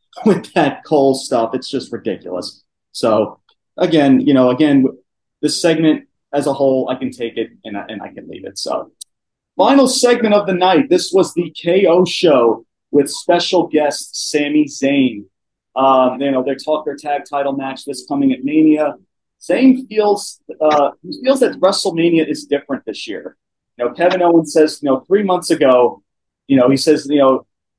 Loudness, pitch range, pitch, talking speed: -15 LUFS, 135-180 Hz, 150 Hz, 180 wpm